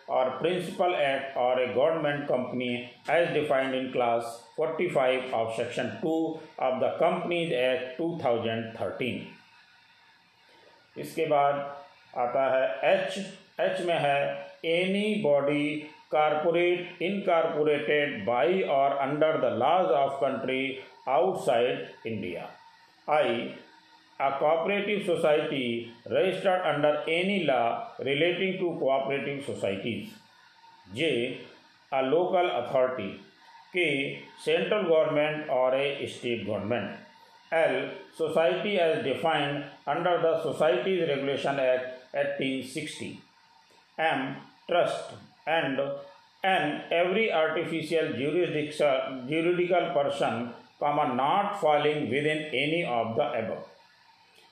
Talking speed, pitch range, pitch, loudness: 100 wpm, 130-170 Hz, 150 Hz, -28 LUFS